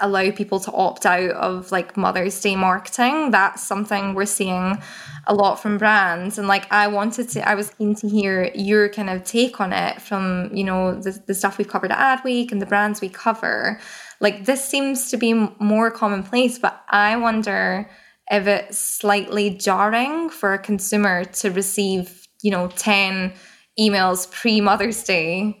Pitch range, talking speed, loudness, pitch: 190-215 Hz, 175 wpm, -20 LUFS, 205 Hz